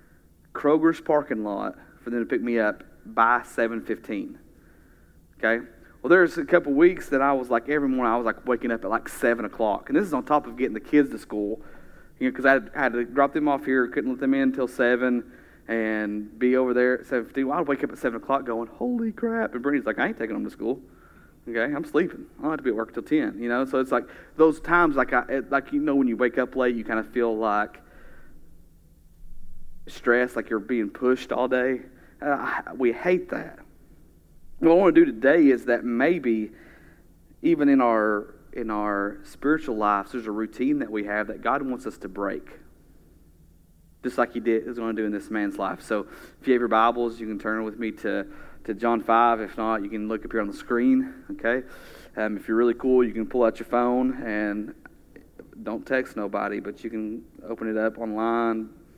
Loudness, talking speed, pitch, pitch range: -25 LUFS, 225 wpm, 120 Hz, 110-130 Hz